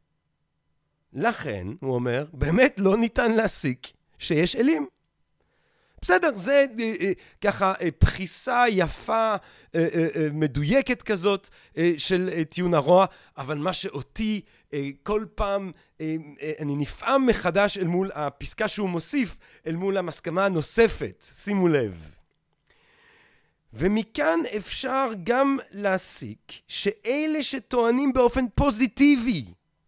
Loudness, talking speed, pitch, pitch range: -24 LUFS, 90 wpm, 195 Hz, 155-235 Hz